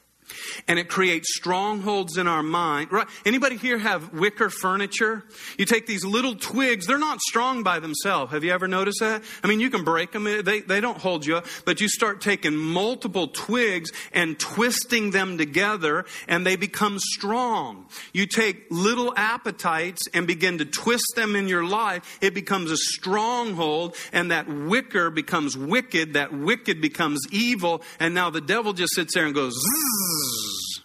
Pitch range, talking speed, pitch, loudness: 170-220 Hz, 170 wpm, 195 Hz, -23 LUFS